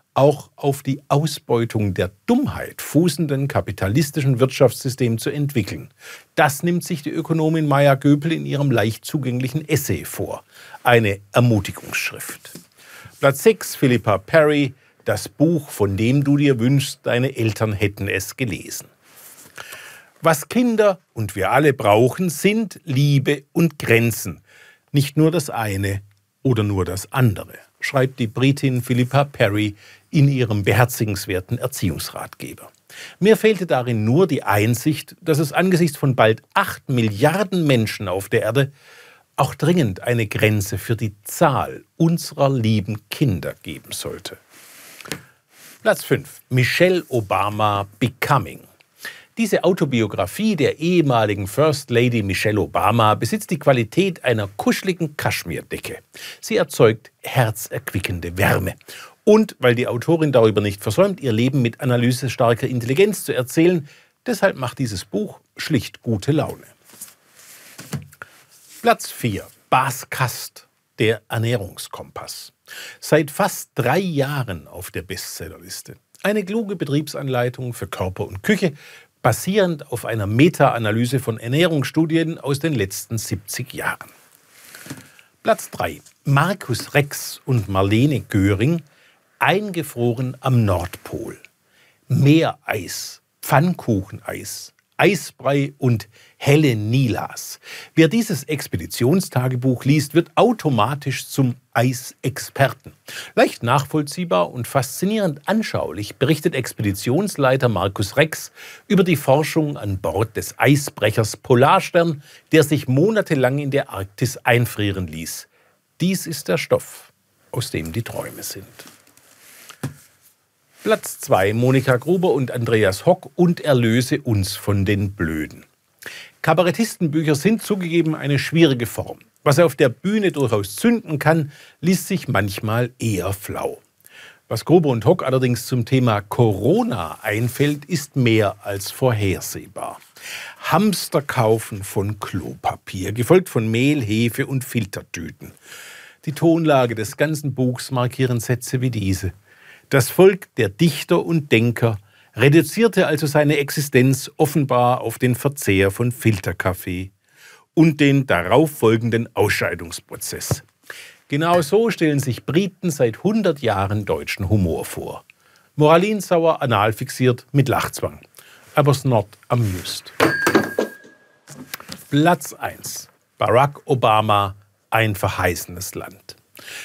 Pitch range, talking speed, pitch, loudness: 110-155 Hz, 115 wpm, 130 Hz, -19 LUFS